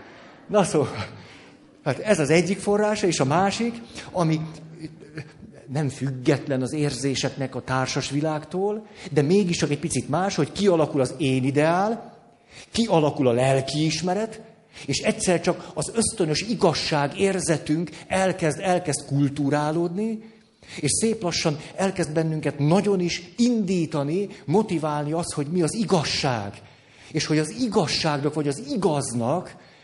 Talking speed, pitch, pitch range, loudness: 130 wpm, 160 Hz, 145-190 Hz, -24 LUFS